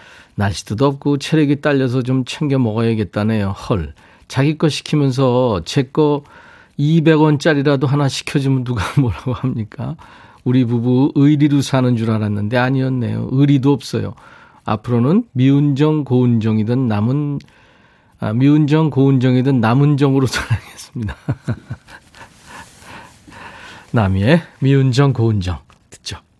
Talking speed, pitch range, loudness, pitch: 265 characters per minute, 115-145 Hz, -16 LUFS, 130 Hz